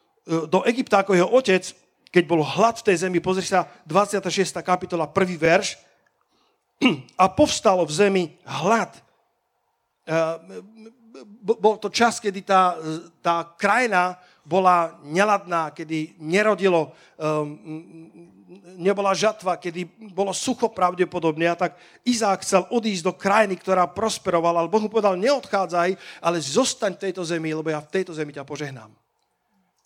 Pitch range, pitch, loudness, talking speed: 170-200 Hz, 180 Hz, -22 LUFS, 130 wpm